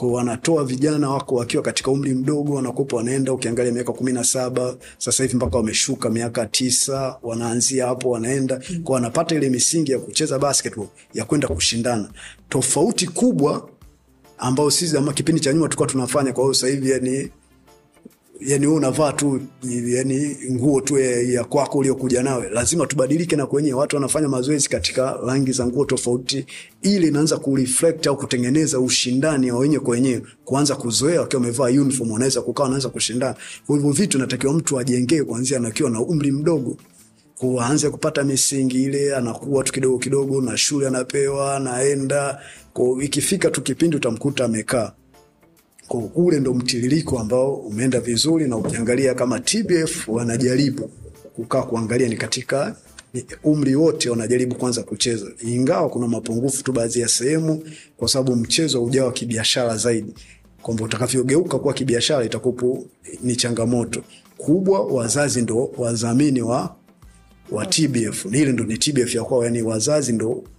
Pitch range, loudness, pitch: 120-140 Hz, -20 LUFS, 130 Hz